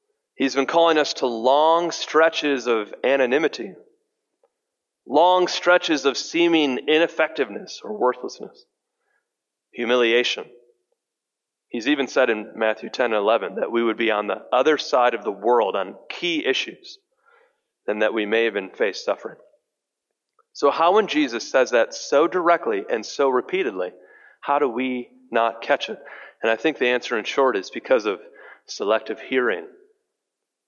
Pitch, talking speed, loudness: 175 Hz, 145 wpm, -21 LUFS